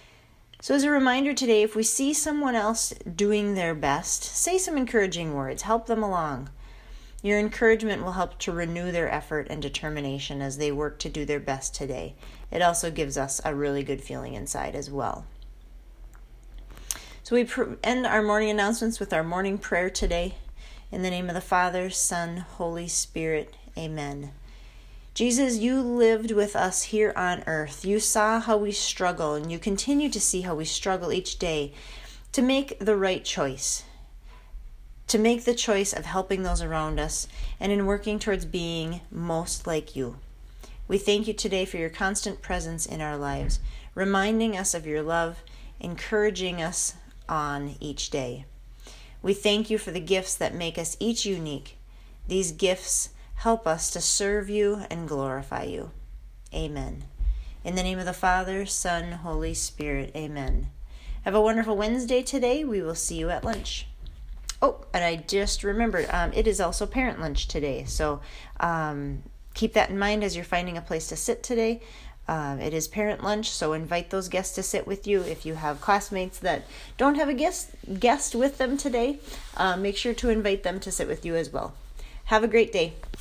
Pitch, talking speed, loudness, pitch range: 180 Hz, 180 wpm, -27 LUFS, 150-215 Hz